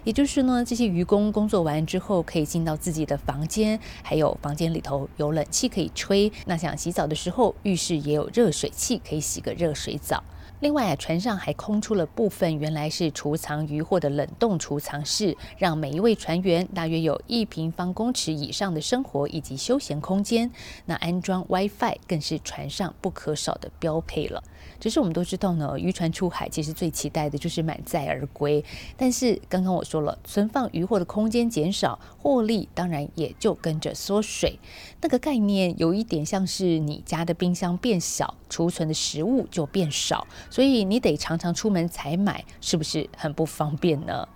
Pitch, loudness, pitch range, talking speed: 175 Hz, -26 LUFS, 155-205 Hz, 290 characters per minute